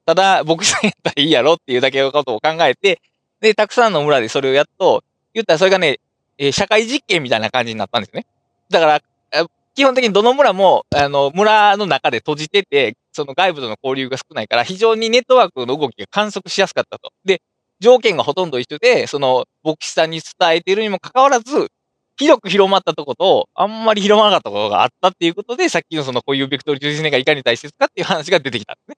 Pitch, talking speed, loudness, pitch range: 185 Hz, 470 characters per minute, -15 LUFS, 145-230 Hz